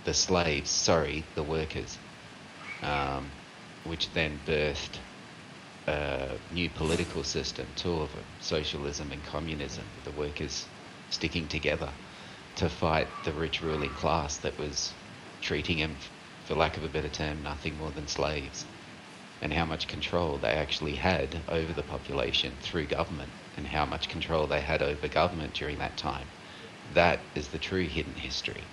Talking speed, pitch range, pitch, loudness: 150 wpm, 75-85 Hz, 80 Hz, -31 LUFS